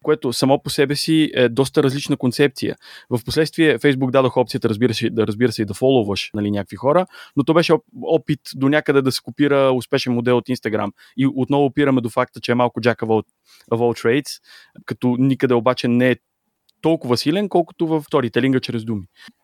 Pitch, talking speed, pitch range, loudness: 130 Hz, 195 wpm, 120-145 Hz, -19 LUFS